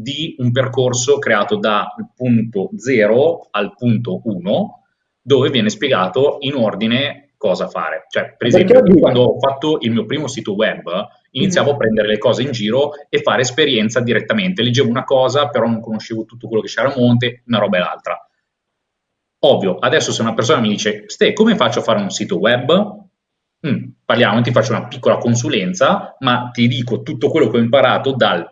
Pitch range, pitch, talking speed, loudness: 115-140 Hz, 125 Hz, 180 wpm, -15 LUFS